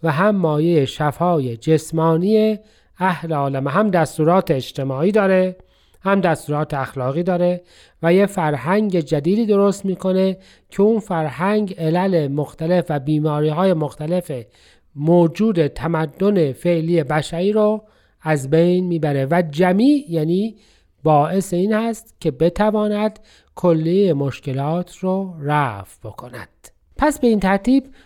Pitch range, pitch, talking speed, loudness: 155-195 Hz, 175 Hz, 120 wpm, -18 LUFS